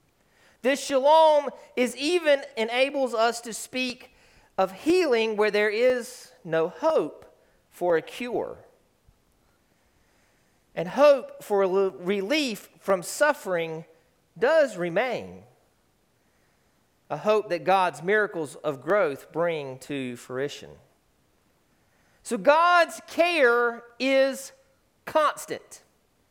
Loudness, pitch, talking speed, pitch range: -25 LUFS, 235 Hz, 100 wpm, 190-280 Hz